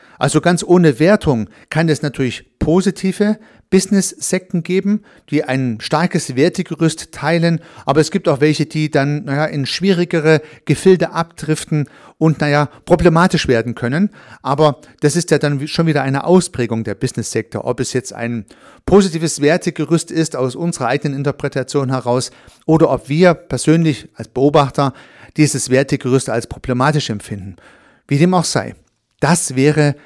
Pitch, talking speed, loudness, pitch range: 150 Hz, 145 wpm, -16 LUFS, 130-170 Hz